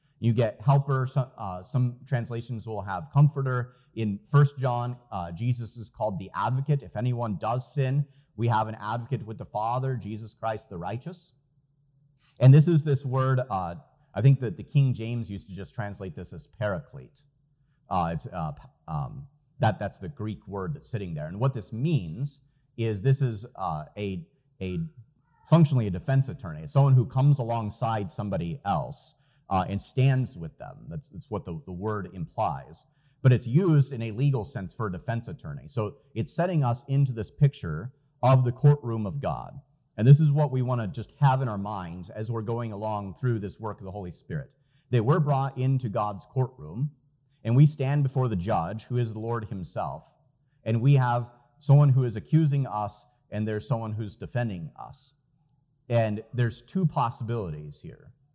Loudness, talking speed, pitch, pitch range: -27 LUFS, 185 wpm, 125 Hz, 110-140 Hz